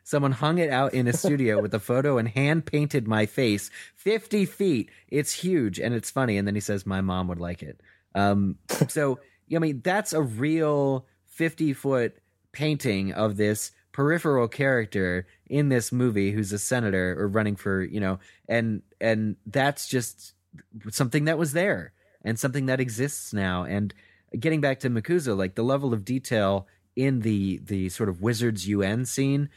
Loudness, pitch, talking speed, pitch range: -26 LUFS, 120 Hz, 175 wpm, 100-140 Hz